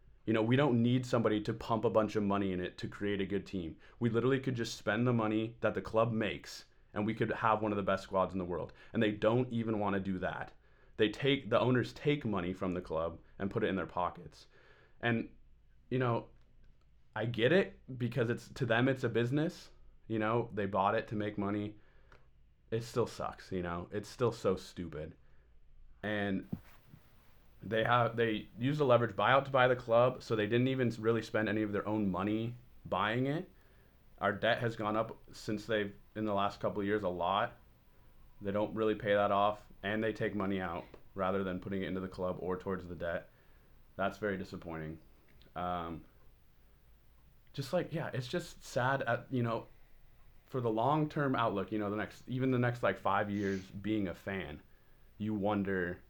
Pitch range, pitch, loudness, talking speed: 100-120 Hz, 110 Hz, -34 LUFS, 200 wpm